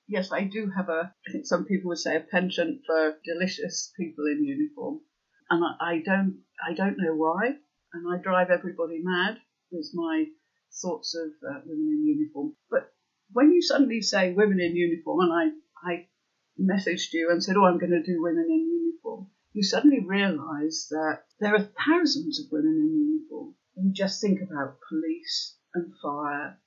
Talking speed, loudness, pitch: 180 wpm, -27 LUFS, 190 Hz